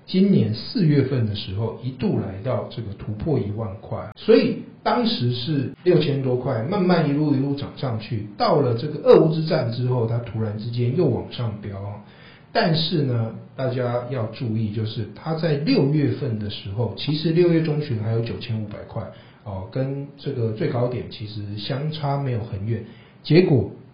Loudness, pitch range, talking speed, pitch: -23 LUFS, 110-145 Hz, 260 characters per minute, 125 Hz